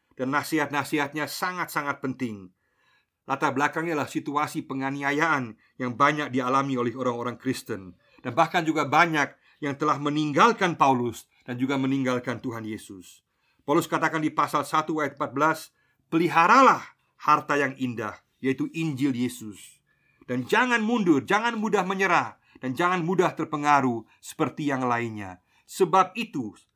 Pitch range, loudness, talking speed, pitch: 125-155 Hz, -25 LUFS, 130 wpm, 140 Hz